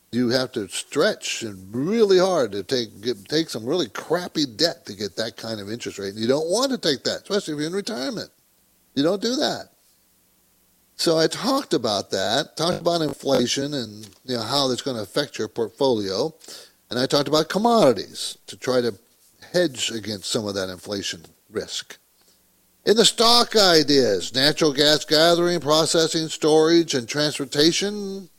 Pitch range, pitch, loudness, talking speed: 120-170 Hz, 150 Hz, -21 LUFS, 175 wpm